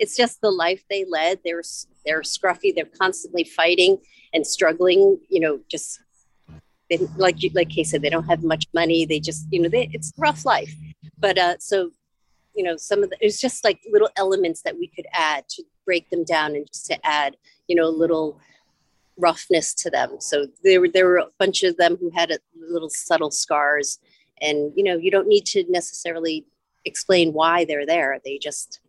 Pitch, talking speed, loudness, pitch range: 170 Hz, 200 wpm, -21 LUFS, 160-195 Hz